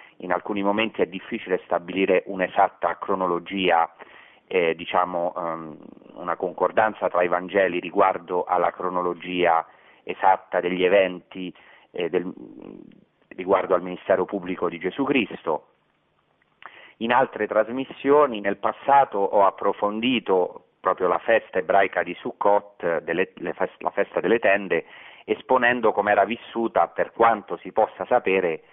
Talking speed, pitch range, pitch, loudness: 120 wpm, 90-105 Hz, 95 Hz, -23 LUFS